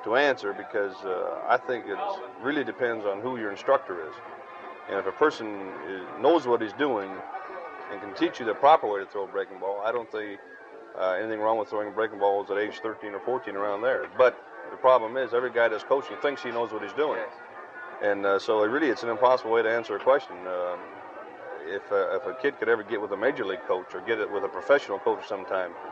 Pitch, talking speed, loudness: 125 Hz, 230 wpm, -27 LUFS